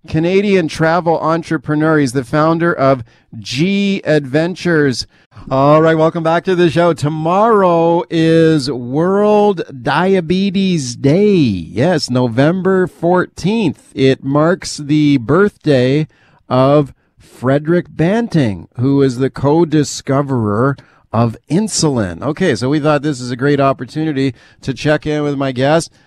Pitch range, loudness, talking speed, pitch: 135-170 Hz, -14 LUFS, 120 wpm, 150 Hz